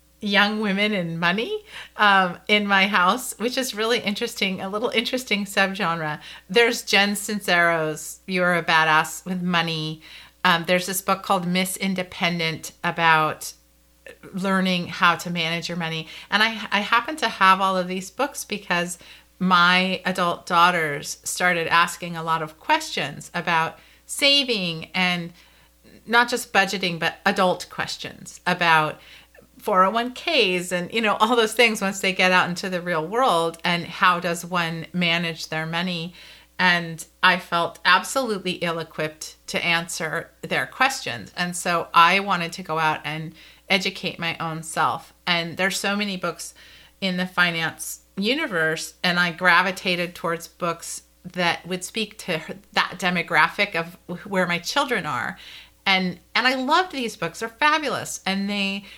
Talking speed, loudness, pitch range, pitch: 150 wpm, -22 LUFS, 170-200 Hz, 180 Hz